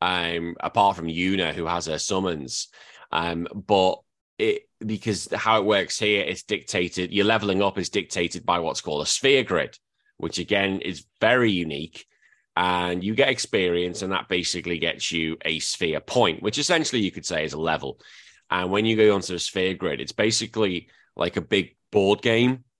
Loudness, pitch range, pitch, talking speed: -24 LUFS, 85-105 Hz, 95 Hz, 185 wpm